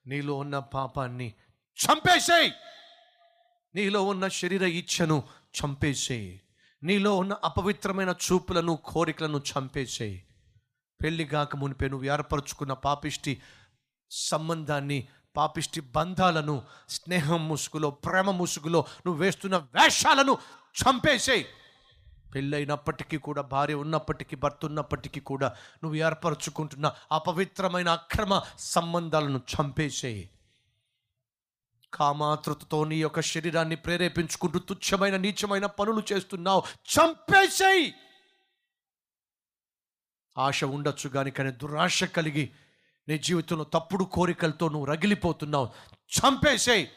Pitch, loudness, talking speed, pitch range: 155 Hz, -27 LUFS, 85 wpm, 140-180 Hz